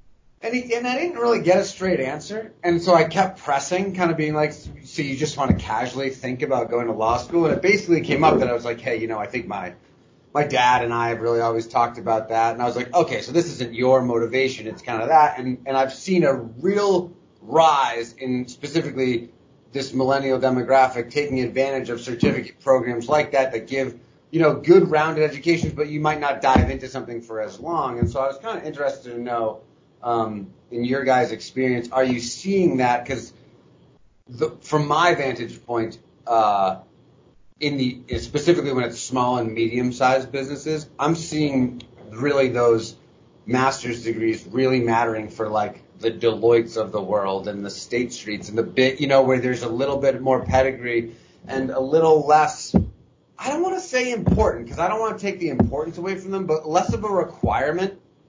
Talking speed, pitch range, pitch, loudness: 200 wpm, 120-155 Hz, 130 Hz, -22 LUFS